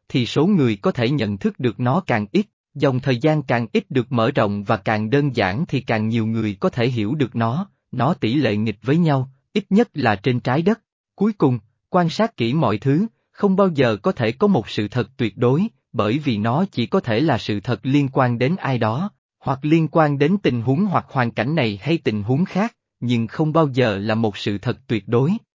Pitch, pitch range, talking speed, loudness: 130 Hz, 115-165 Hz, 235 wpm, -20 LUFS